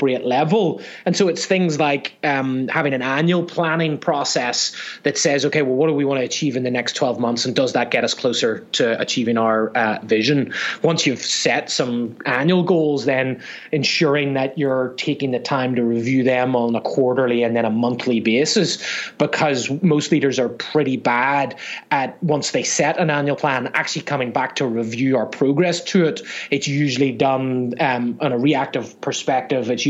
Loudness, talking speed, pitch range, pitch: -19 LUFS, 185 wpm, 125-150 Hz, 135 Hz